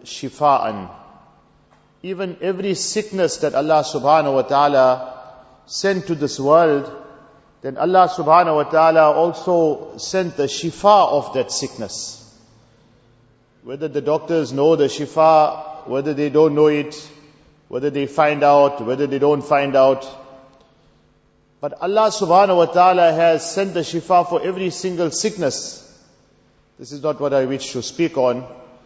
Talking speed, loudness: 140 wpm, -17 LUFS